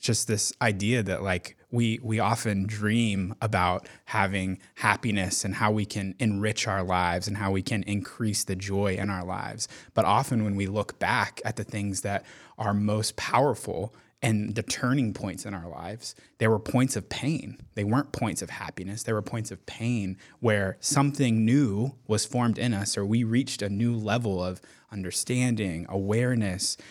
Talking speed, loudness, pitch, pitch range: 180 wpm, -28 LUFS, 105 Hz, 100-115 Hz